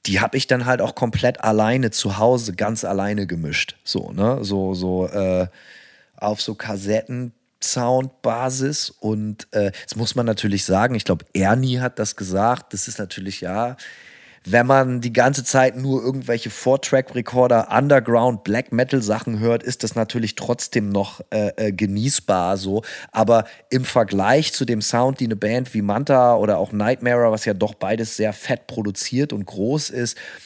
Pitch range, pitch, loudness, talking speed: 105-125 Hz, 115 Hz, -20 LUFS, 170 wpm